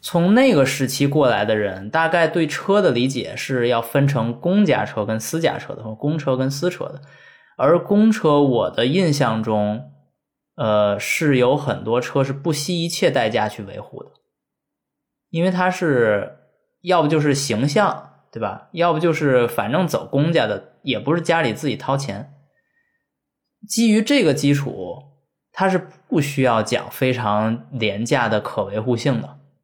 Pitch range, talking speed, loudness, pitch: 120-170 Hz, 225 characters per minute, -19 LUFS, 140 Hz